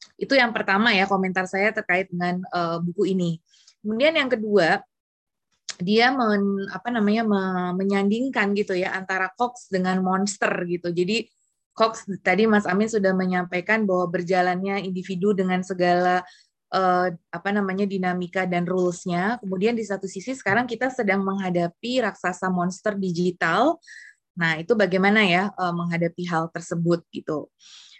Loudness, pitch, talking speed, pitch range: -23 LUFS, 190 Hz, 135 wpm, 180-210 Hz